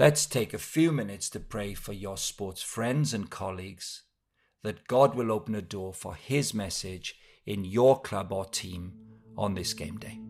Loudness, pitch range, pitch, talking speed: -30 LUFS, 95-115 Hz, 105 Hz, 180 wpm